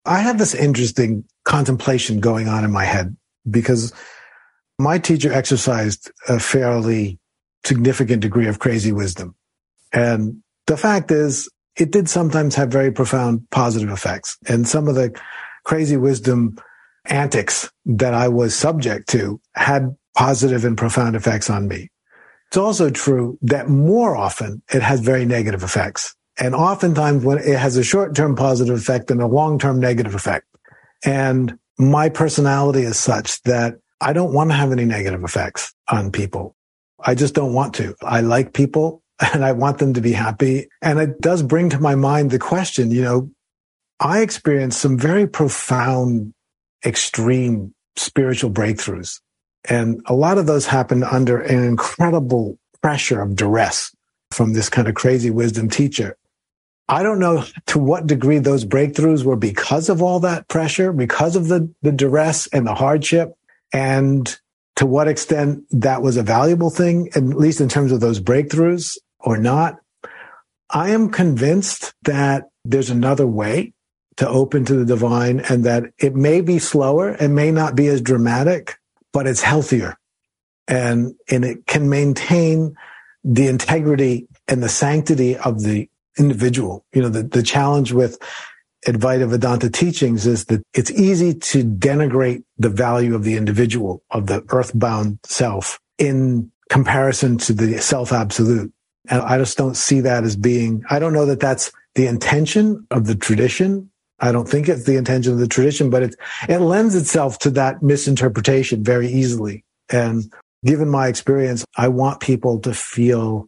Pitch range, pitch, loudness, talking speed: 120-145 Hz, 130 Hz, -17 LUFS, 160 wpm